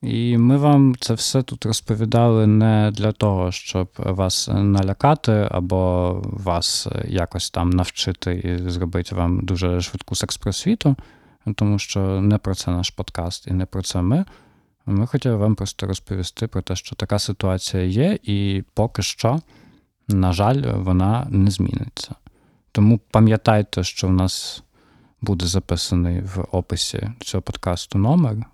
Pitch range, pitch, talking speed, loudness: 90-115 Hz, 100 Hz, 145 wpm, -20 LUFS